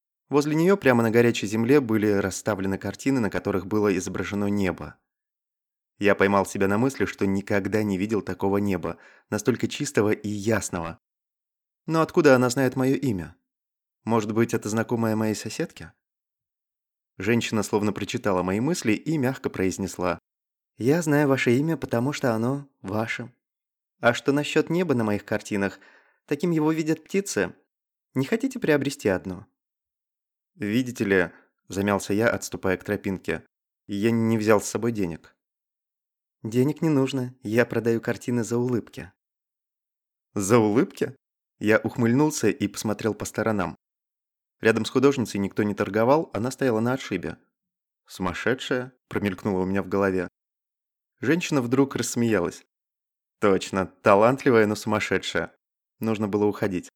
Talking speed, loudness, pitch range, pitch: 135 wpm, -24 LUFS, 100-130 Hz, 110 Hz